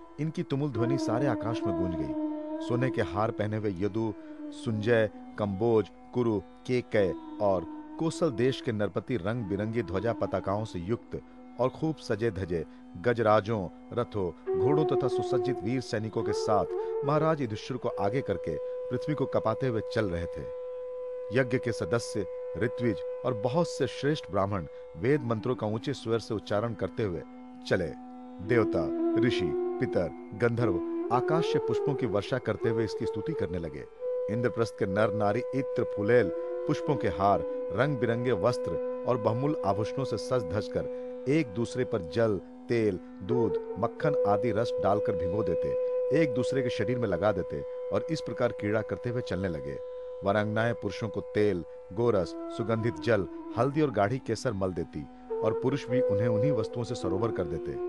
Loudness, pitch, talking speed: -30 LUFS, 125 Hz, 160 wpm